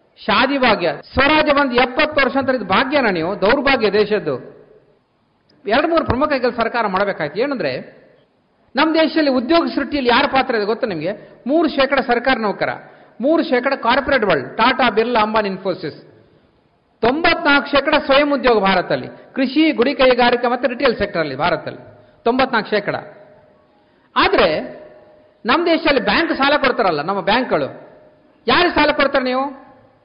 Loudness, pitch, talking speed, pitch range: -16 LUFS, 265 Hz, 130 wpm, 225-285 Hz